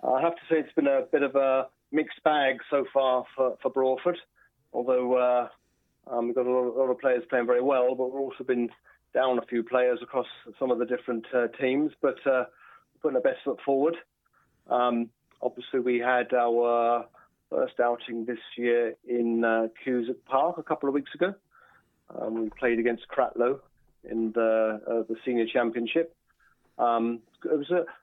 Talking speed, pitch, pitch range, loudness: 185 wpm, 125 Hz, 120-135 Hz, -27 LUFS